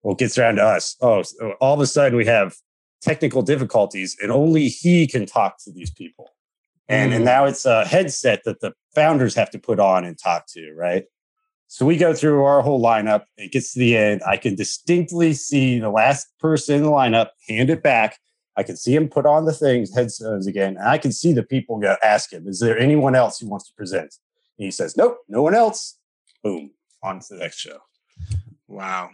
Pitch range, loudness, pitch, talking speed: 115-155 Hz, -19 LUFS, 135 Hz, 220 wpm